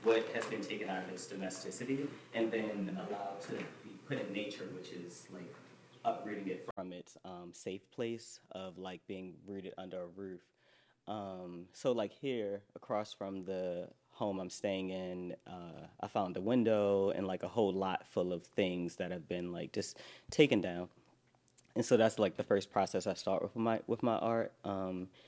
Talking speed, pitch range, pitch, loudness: 190 wpm, 90-110 Hz, 95 Hz, -38 LUFS